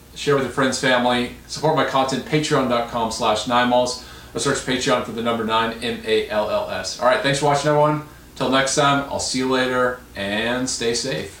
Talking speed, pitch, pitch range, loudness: 180 wpm, 130 Hz, 120-140 Hz, -20 LUFS